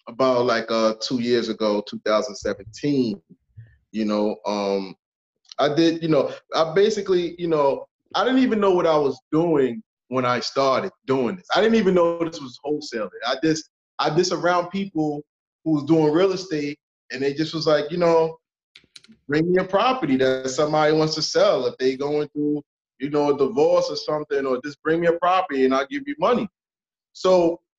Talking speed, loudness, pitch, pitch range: 190 wpm, -22 LUFS, 150 Hz, 130-175 Hz